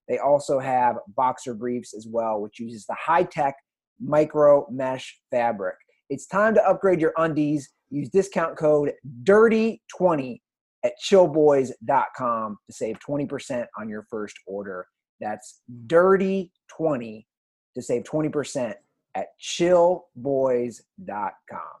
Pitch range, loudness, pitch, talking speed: 120-170 Hz, -23 LUFS, 145 Hz, 115 wpm